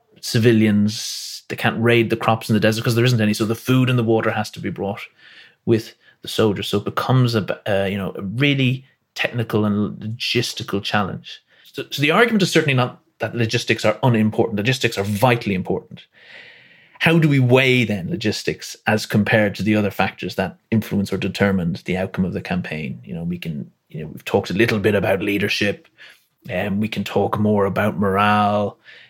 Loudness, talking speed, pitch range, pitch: -19 LUFS, 200 wpm, 105-125 Hz, 110 Hz